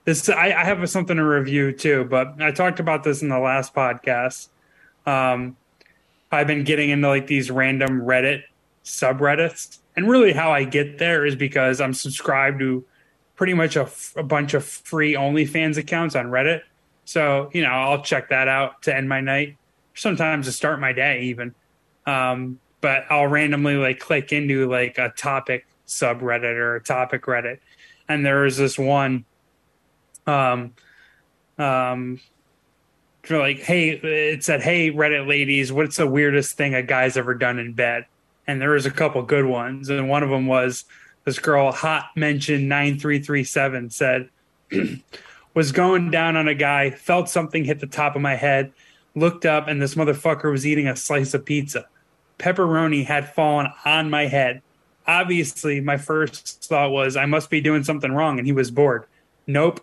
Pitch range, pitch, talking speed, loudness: 130-155 Hz, 145 Hz, 175 wpm, -20 LUFS